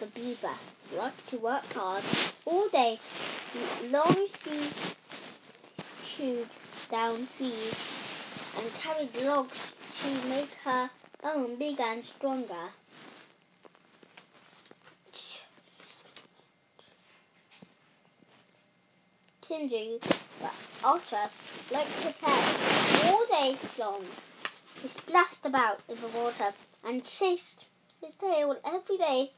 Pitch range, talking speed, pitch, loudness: 235-310 Hz, 90 wpm, 265 Hz, -31 LUFS